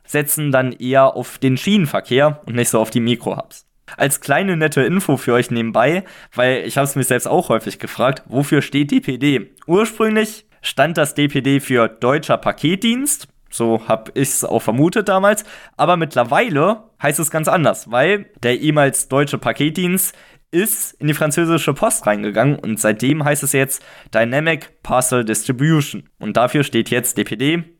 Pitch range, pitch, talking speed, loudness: 125-165 Hz, 140 Hz, 160 wpm, -17 LUFS